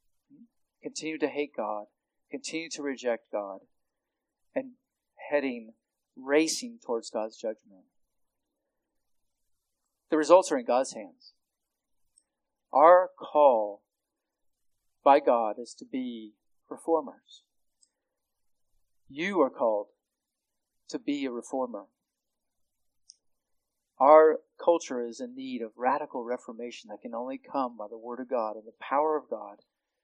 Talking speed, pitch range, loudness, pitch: 115 wpm, 115-165 Hz, -27 LUFS, 140 Hz